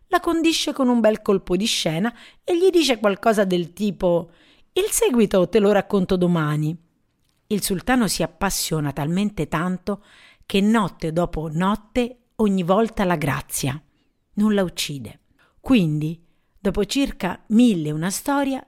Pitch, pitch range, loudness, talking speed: 200 Hz, 170-230 Hz, -21 LUFS, 140 wpm